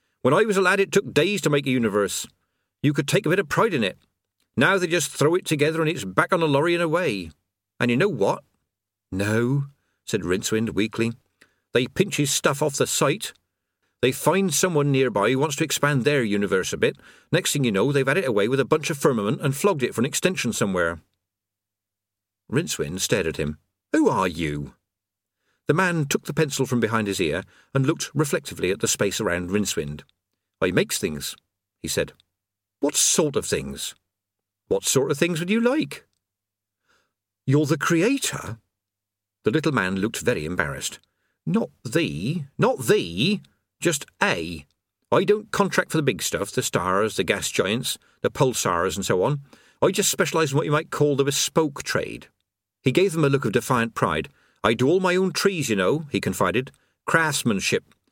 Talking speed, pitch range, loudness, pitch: 190 wpm, 100-160 Hz, -23 LUFS, 135 Hz